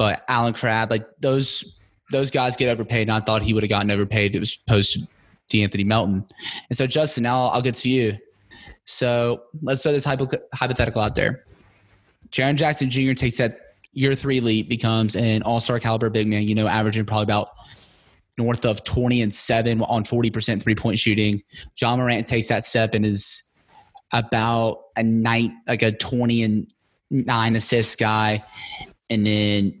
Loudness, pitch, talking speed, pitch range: -21 LUFS, 115 Hz, 175 wpm, 110-125 Hz